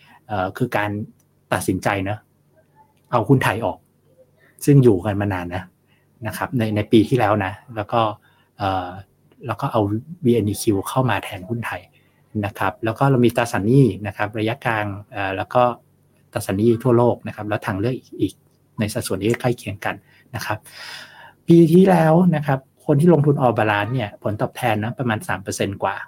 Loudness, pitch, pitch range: -20 LUFS, 110 Hz, 105-130 Hz